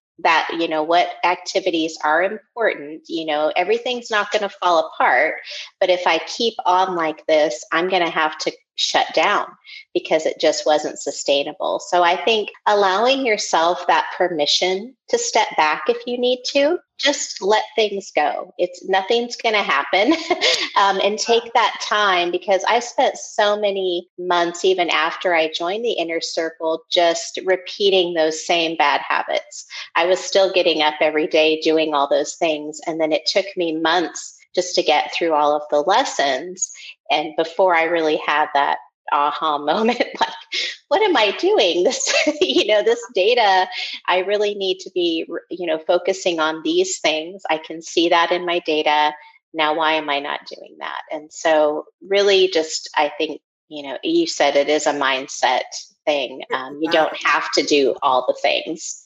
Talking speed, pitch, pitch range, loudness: 175 wpm, 180 Hz, 155-215 Hz, -19 LUFS